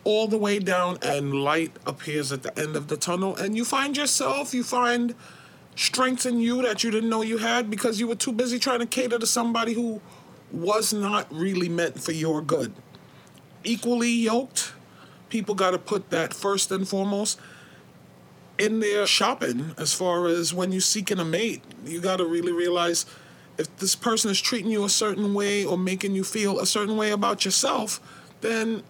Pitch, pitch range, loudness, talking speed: 205 Hz, 175-230 Hz, -25 LUFS, 185 wpm